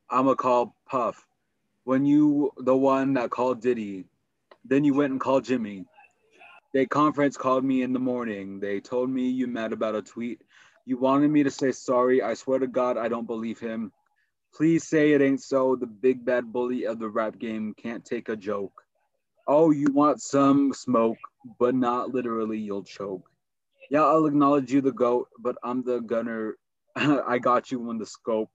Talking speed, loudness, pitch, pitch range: 185 wpm, -25 LUFS, 125 Hz, 115-135 Hz